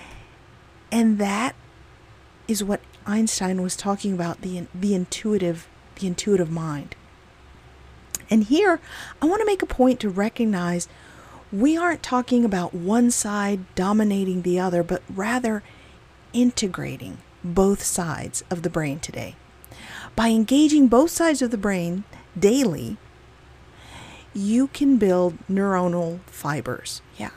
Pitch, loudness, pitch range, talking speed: 200 Hz, -22 LUFS, 175-230 Hz, 125 wpm